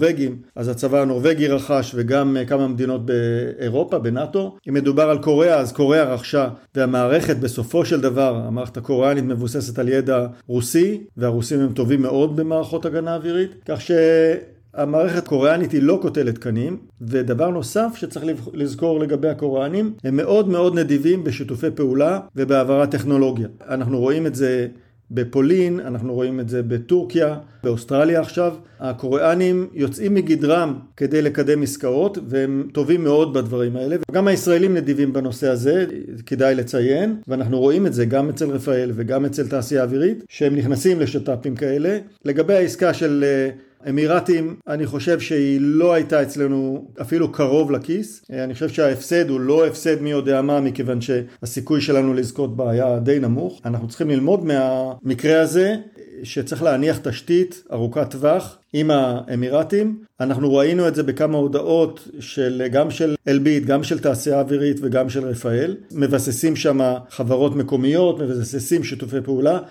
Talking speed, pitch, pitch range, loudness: 140 wpm, 140 Hz, 130-160 Hz, -19 LUFS